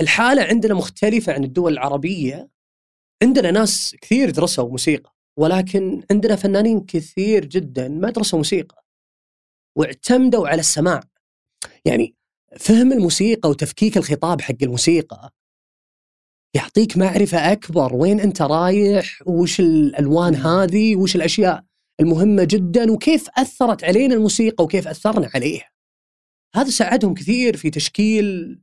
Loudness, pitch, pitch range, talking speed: -17 LUFS, 190 Hz, 160-215 Hz, 115 wpm